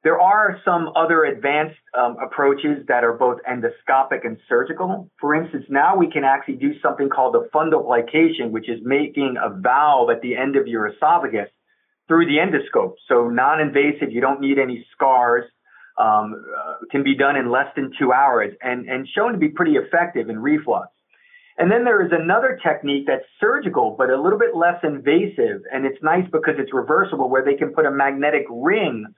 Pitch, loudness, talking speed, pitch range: 145 Hz, -19 LUFS, 190 wpm, 130-185 Hz